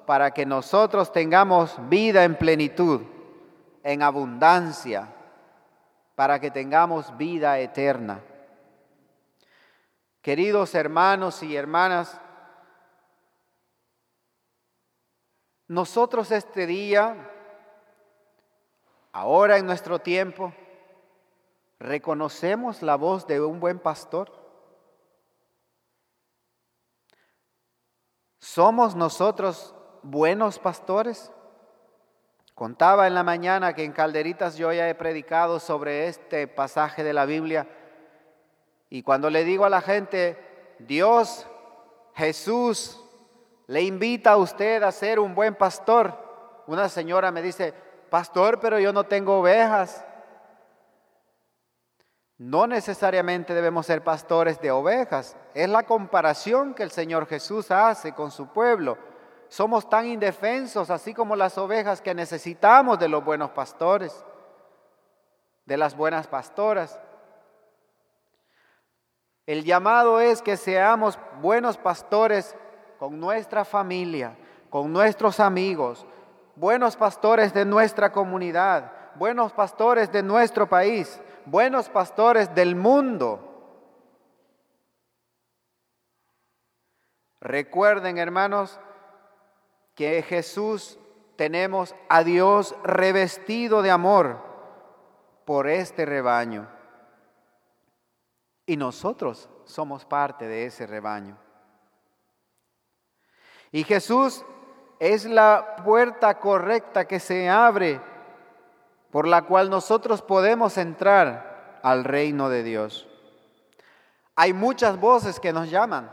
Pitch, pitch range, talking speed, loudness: 185 Hz, 155-215 Hz, 95 wpm, -22 LUFS